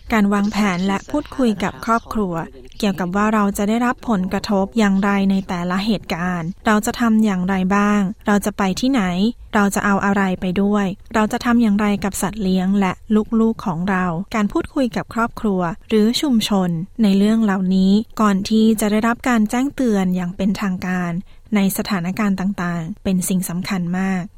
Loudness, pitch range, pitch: -19 LUFS, 190-220 Hz, 200 Hz